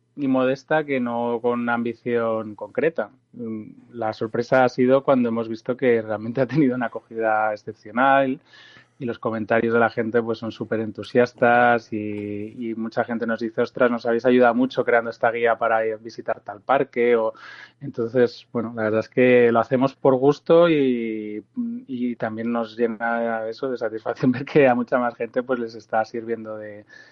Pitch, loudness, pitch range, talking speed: 120 Hz, -22 LUFS, 115-125 Hz, 180 wpm